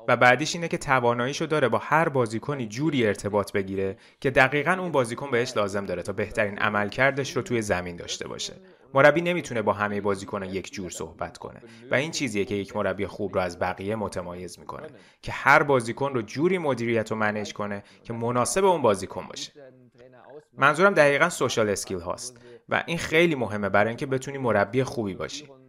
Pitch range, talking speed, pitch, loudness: 105-140 Hz, 180 wpm, 120 Hz, -25 LUFS